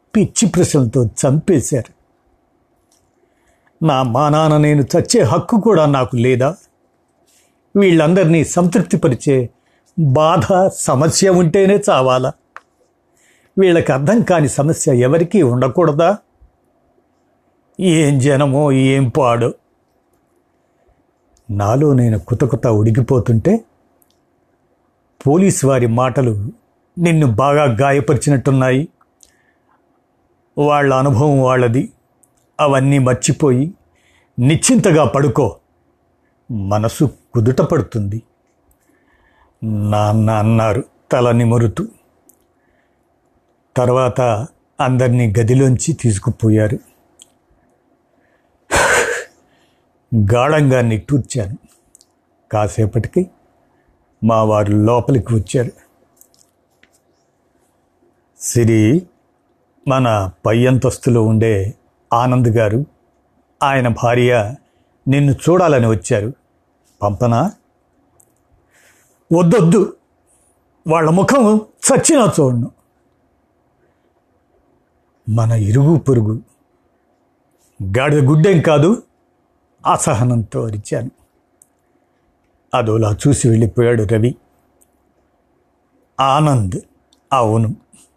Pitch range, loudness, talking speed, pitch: 115-155 Hz, -14 LUFS, 65 wpm, 130 Hz